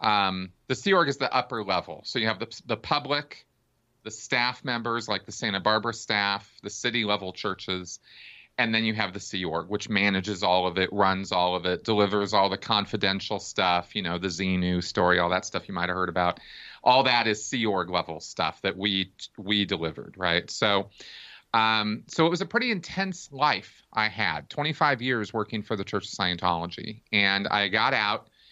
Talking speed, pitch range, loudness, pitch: 200 wpm, 95-115 Hz, -26 LUFS, 105 Hz